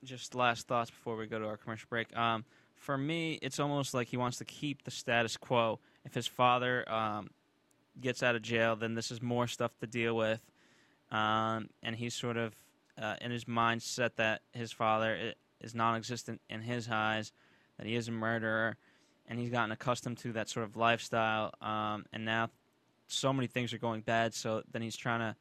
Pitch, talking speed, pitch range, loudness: 115 Hz, 200 wpm, 110-125 Hz, -35 LUFS